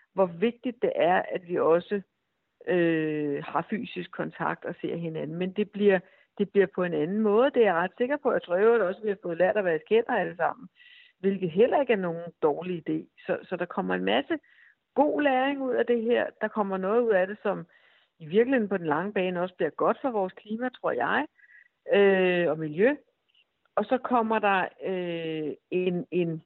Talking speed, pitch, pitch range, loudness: 215 wpm, 195 Hz, 175-240 Hz, -27 LUFS